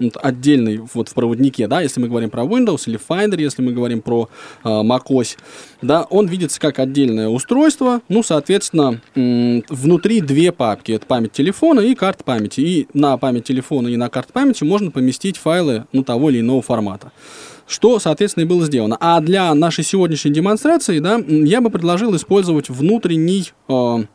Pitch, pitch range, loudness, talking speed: 145 Hz, 120-185 Hz, -16 LUFS, 170 wpm